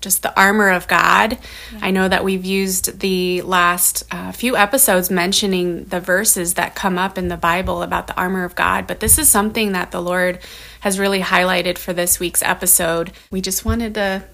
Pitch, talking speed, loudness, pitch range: 185 Hz, 195 wpm, -16 LUFS, 180-195 Hz